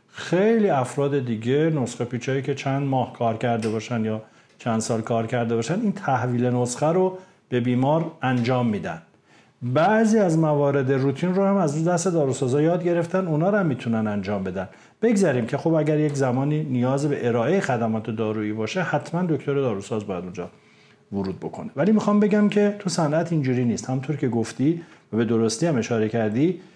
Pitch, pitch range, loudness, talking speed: 135 Hz, 115-165 Hz, -23 LUFS, 175 wpm